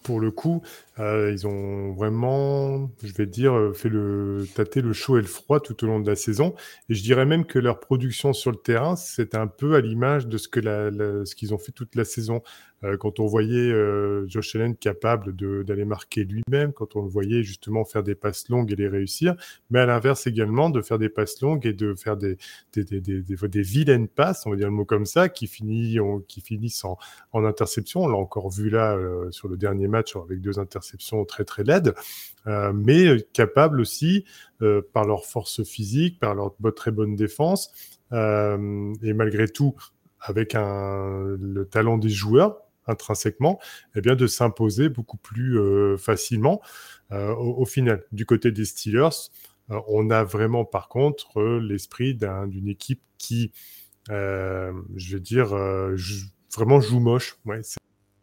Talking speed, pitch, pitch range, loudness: 195 wpm, 110 Hz, 100-120 Hz, -24 LUFS